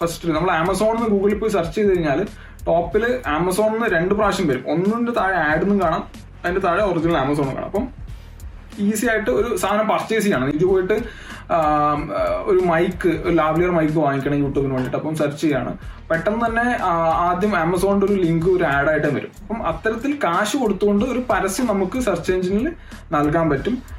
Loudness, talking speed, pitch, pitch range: -20 LUFS, 165 wpm, 185 Hz, 155-210 Hz